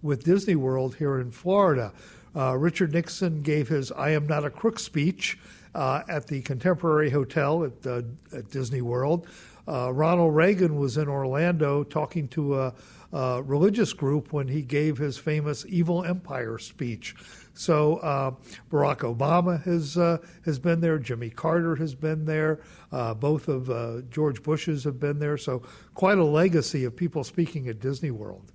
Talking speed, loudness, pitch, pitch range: 170 wpm, -26 LUFS, 150 Hz, 130-165 Hz